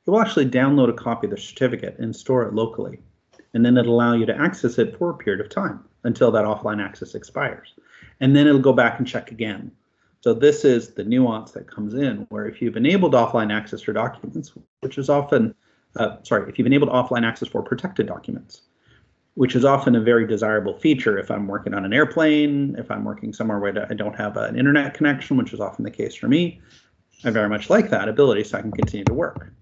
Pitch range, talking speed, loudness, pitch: 110-145 Hz, 225 wpm, -21 LUFS, 125 Hz